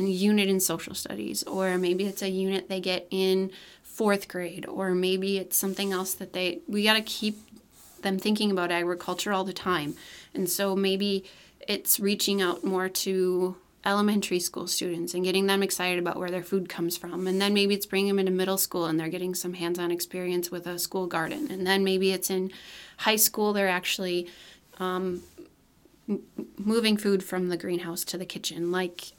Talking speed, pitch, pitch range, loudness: 190 wpm, 185 Hz, 180-195 Hz, -27 LUFS